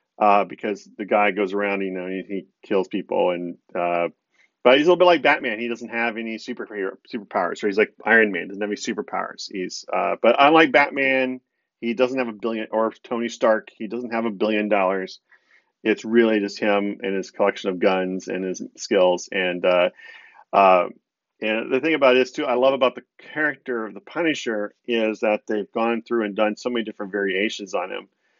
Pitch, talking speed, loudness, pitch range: 110 Hz, 205 wpm, -22 LUFS, 100-120 Hz